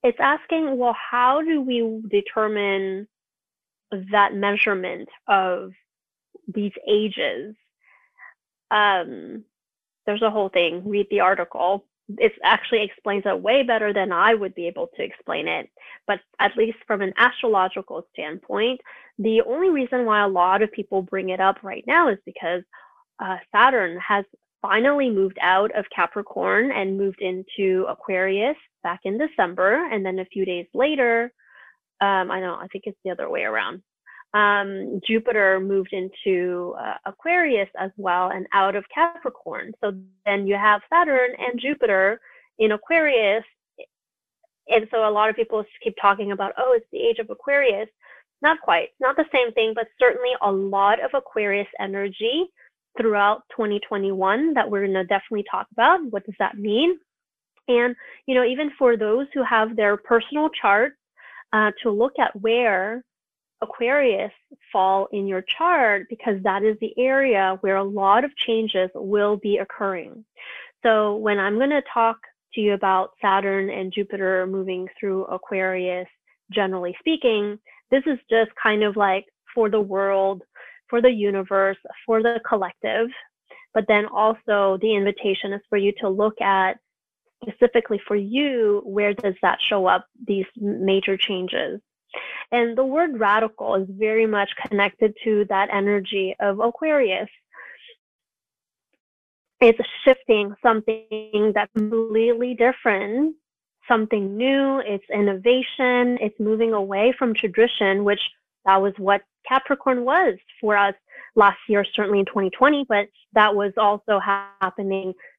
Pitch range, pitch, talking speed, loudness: 195-245 Hz, 210 Hz, 145 wpm, -21 LUFS